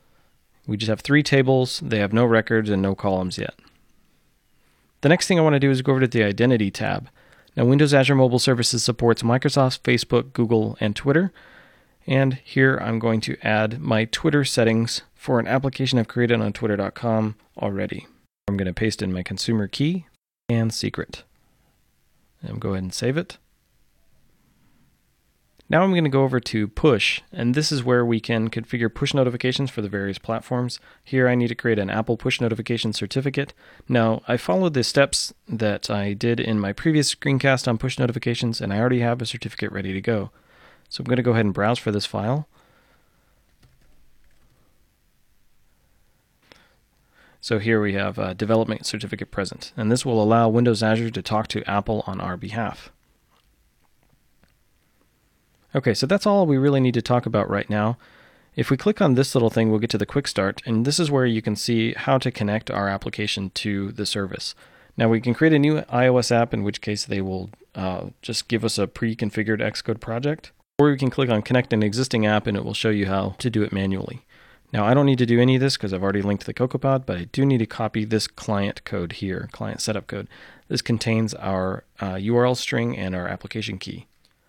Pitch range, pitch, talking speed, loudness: 105-130 Hz, 115 Hz, 195 wpm, -22 LUFS